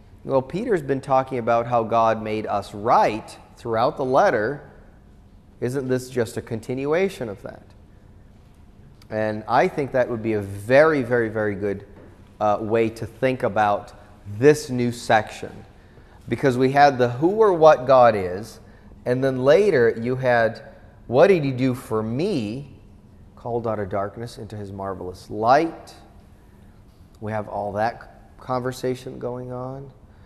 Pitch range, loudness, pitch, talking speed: 100-130 Hz, -21 LUFS, 110 Hz, 145 wpm